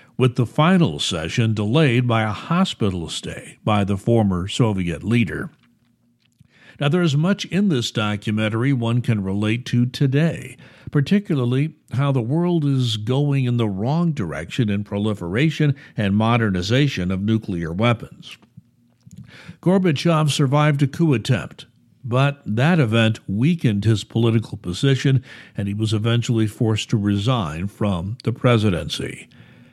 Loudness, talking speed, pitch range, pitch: -20 LUFS, 130 wpm, 110-145 Hz, 120 Hz